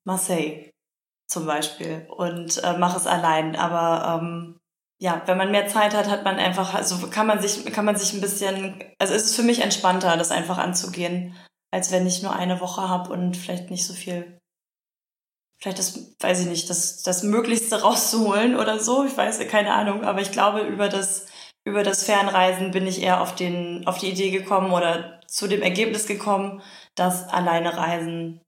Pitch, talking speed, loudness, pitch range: 185 Hz, 190 wpm, -23 LUFS, 175-200 Hz